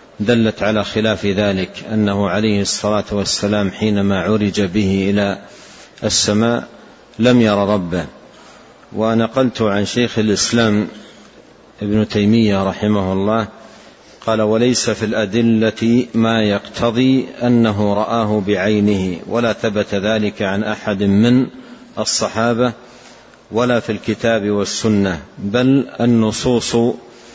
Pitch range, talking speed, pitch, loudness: 105-115 Hz, 100 wpm, 110 Hz, -16 LUFS